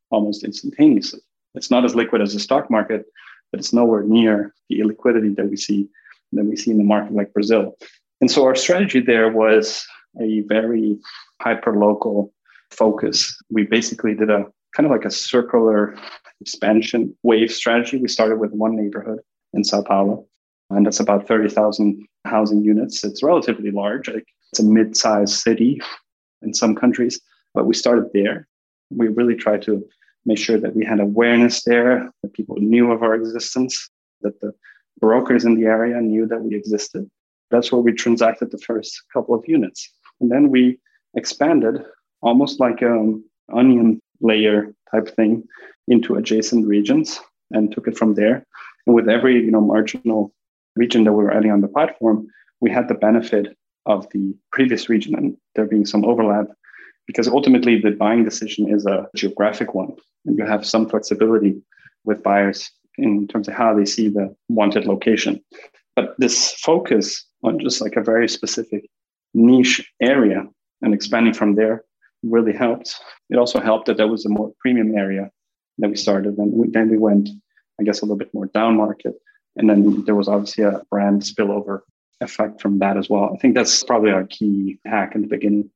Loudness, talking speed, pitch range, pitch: -18 LUFS, 175 wpm, 105-115 Hz, 110 Hz